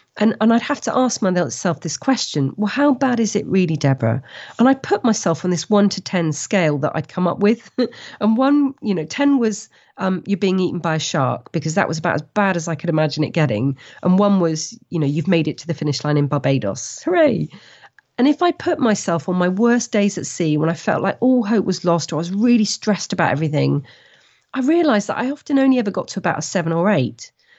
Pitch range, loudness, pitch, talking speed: 160-230 Hz, -19 LUFS, 190 Hz, 240 wpm